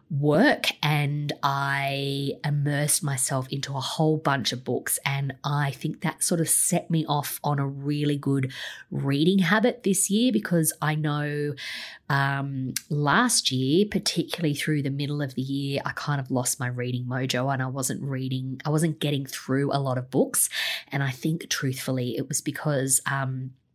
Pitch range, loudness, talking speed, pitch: 135-155 Hz, -25 LUFS, 170 wpm, 140 Hz